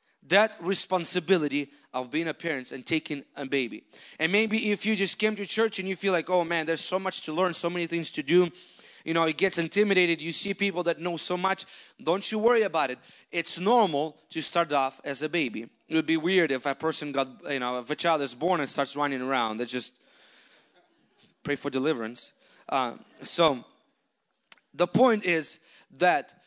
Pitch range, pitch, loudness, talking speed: 145-185 Hz, 165 Hz, -26 LUFS, 200 wpm